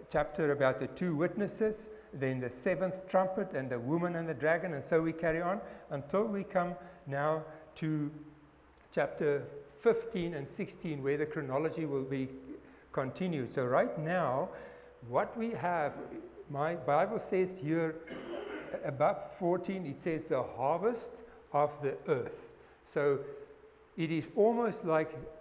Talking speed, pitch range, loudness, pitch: 140 wpm, 150-205 Hz, -34 LUFS, 170 Hz